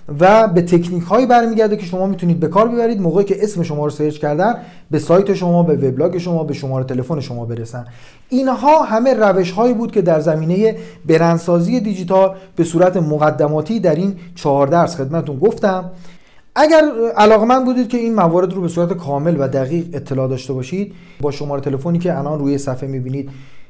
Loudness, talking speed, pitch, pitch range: -15 LUFS, 180 wpm, 175 Hz, 150-200 Hz